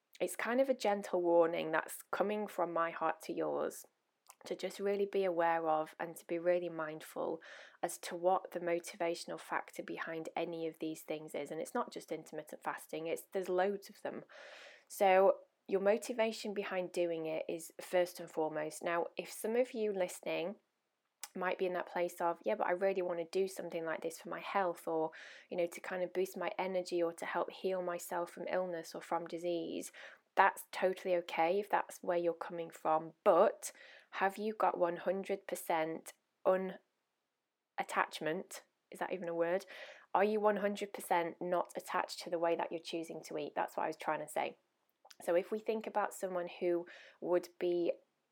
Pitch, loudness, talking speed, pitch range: 180 Hz, -37 LUFS, 185 wpm, 170-195 Hz